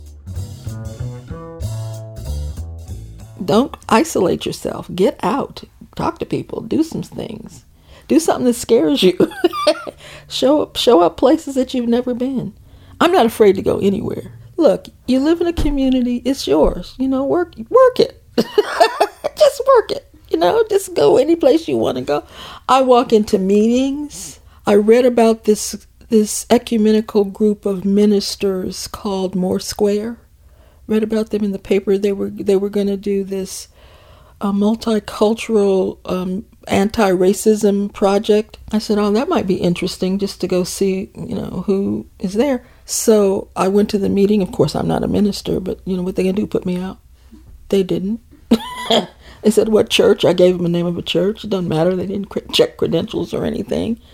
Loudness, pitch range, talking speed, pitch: -17 LUFS, 185-240 Hz, 170 wpm, 205 Hz